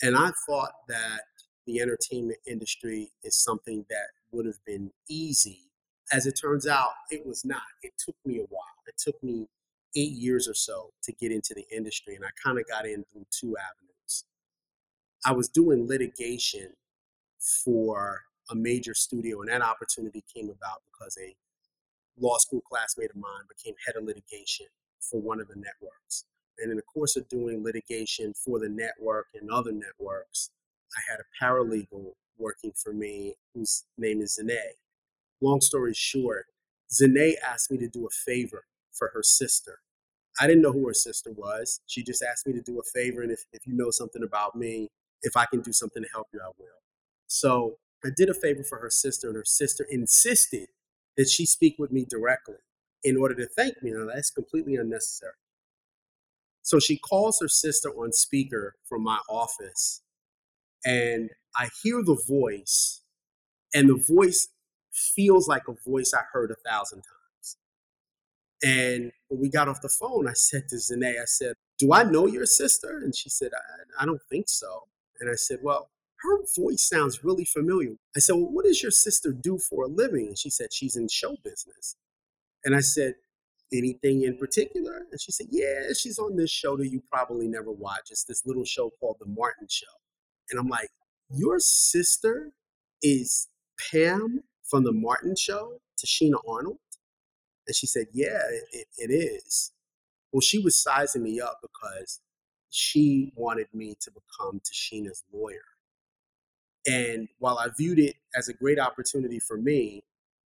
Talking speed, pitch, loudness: 175 wpm, 135 Hz, -26 LUFS